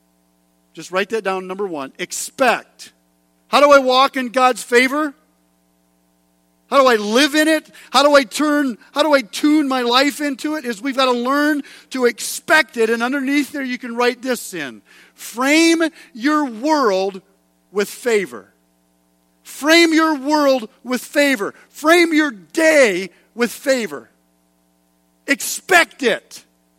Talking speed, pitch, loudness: 145 wpm, 250 Hz, -16 LUFS